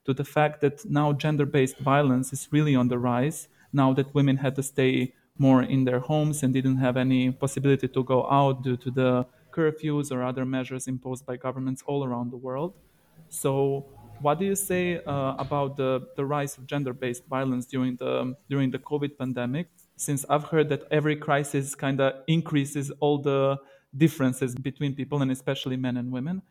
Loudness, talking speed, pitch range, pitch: -26 LUFS, 190 wpm, 130-145 Hz, 135 Hz